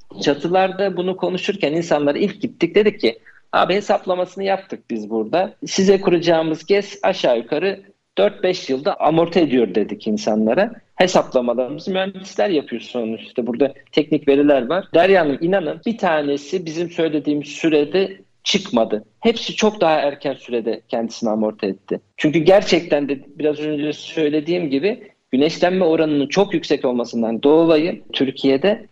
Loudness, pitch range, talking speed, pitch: -19 LUFS, 140-190 Hz, 130 wpm, 155 Hz